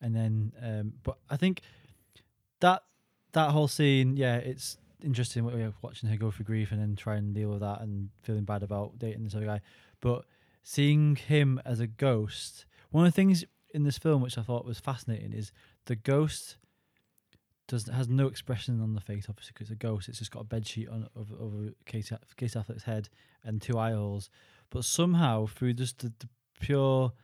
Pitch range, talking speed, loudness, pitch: 110-130 Hz, 200 wpm, -31 LUFS, 115 Hz